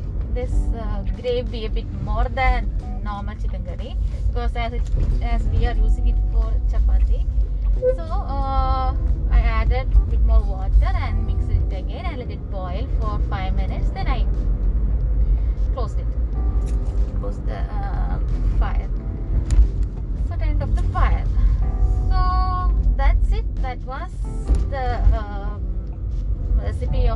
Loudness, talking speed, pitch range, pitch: -23 LUFS, 135 wpm, 70-95 Hz, 85 Hz